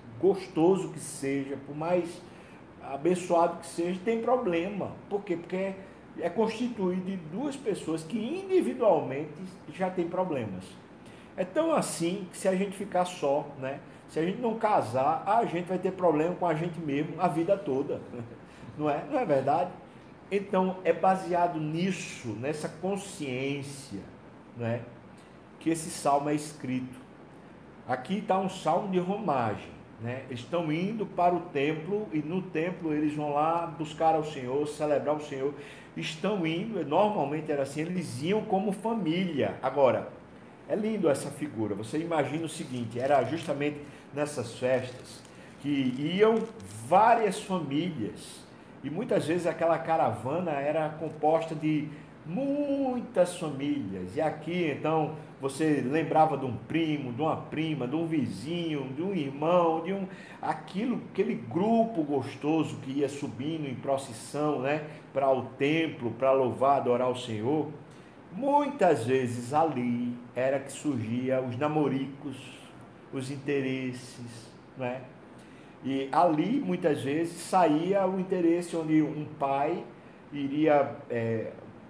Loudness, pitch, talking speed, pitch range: -29 LUFS, 155 Hz, 135 wpm, 140-180 Hz